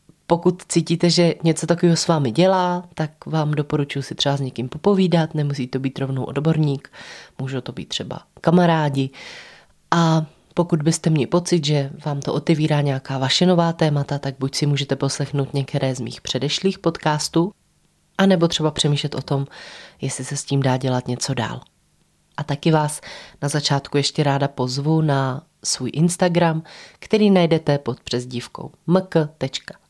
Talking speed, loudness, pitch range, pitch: 155 wpm, -20 LUFS, 135-170 Hz, 150 Hz